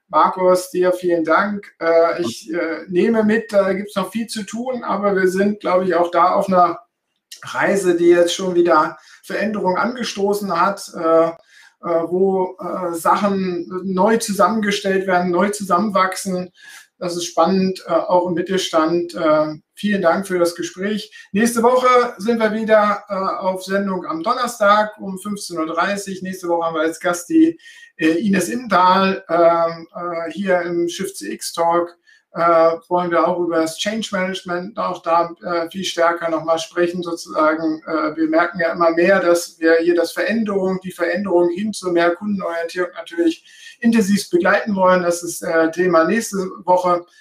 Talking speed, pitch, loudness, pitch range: 155 wpm, 180 Hz, -18 LUFS, 170-200 Hz